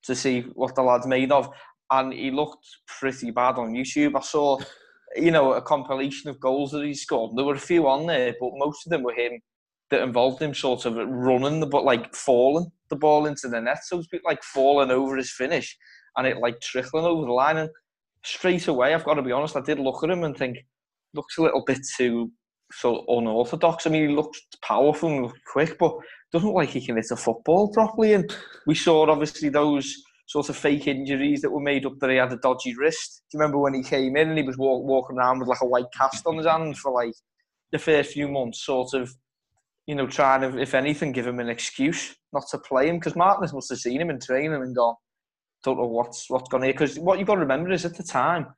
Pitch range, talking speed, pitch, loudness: 130-155 Hz, 245 wpm, 140 Hz, -24 LUFS